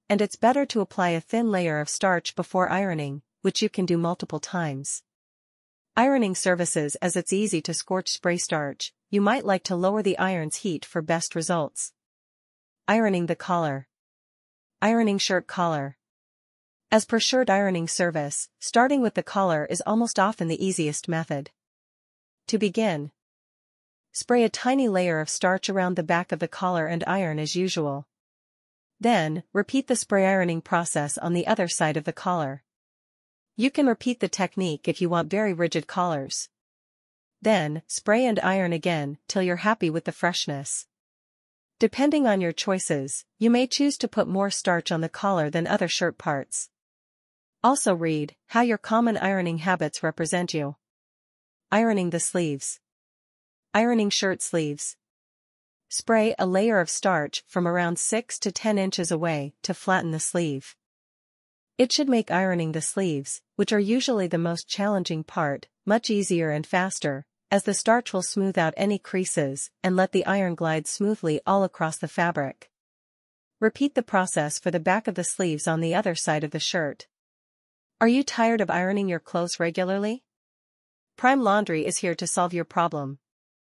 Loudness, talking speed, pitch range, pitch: -25 LUFS, 165 wpm, 165-205 Hz, 180 Hz